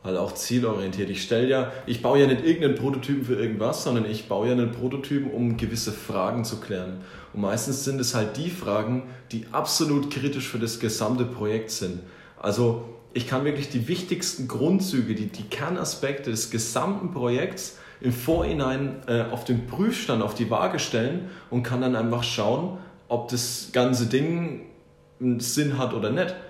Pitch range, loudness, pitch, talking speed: 115-140 Hz, -26 LUFS, 125 Hz, 175 wpm